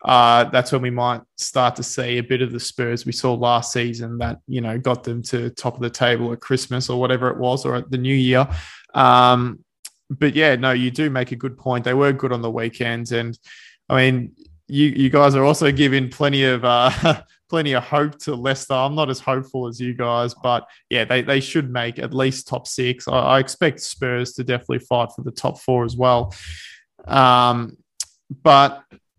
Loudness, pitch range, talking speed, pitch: -19 LUFS, 120-135 Hz, 210 wpm, 125 Hz